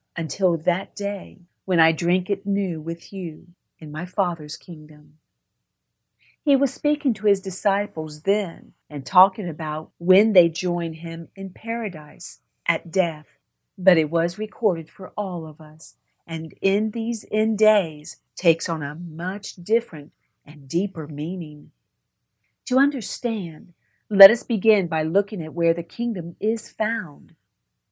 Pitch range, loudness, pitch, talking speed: 160-205 Hz, -23 LUFS, 180 Hz, 140 wpm